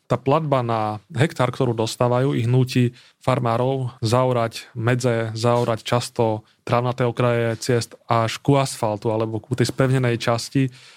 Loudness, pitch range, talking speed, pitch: -21 LUFS, 115-130 Hz, 130 wpm, 120 Hz